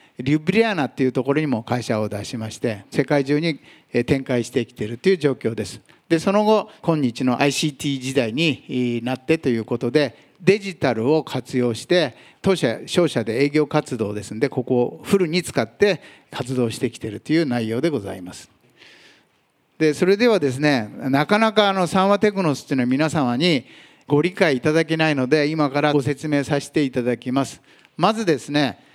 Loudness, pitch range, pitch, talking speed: -21 LUFS, 125-160 Hz, 145 Hz, 360 characters per minute